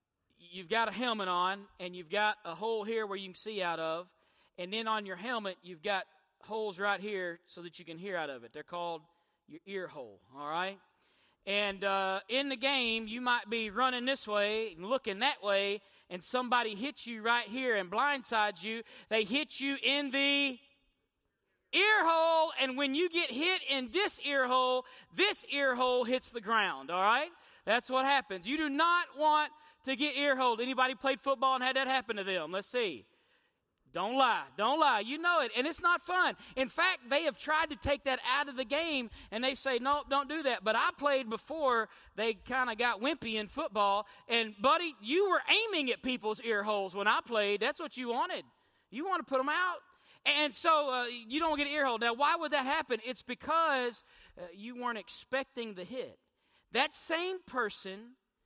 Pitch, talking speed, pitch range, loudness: 250 Hz, 200 wpm, 210-285 Hz, -32 LUFS